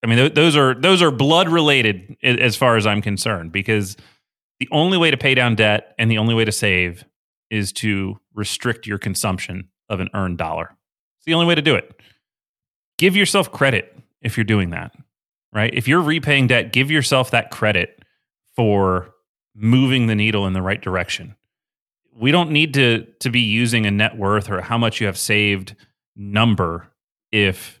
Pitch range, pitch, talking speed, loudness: 100-130 Hz, 110 Hz, 185 wpm, -17 LUFS